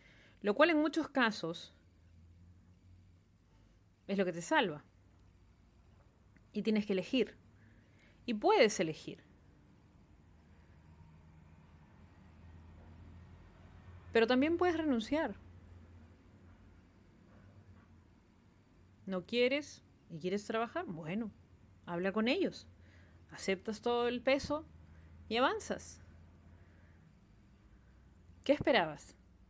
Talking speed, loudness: 75 wpm, -34 LUFS